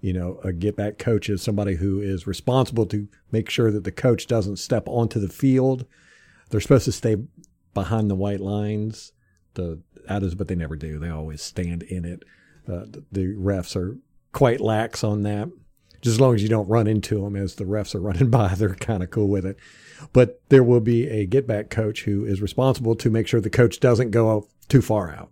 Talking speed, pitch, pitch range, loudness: 215 wpm, 105 Hz, 95-115 Hz, -22 LUFS